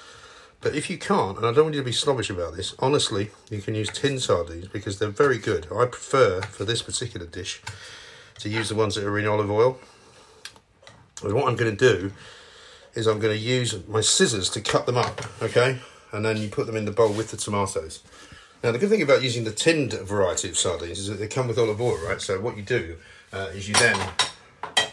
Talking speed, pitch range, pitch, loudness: 230 wpm, 105-120 Hz, 110 Hz, -24 LUFS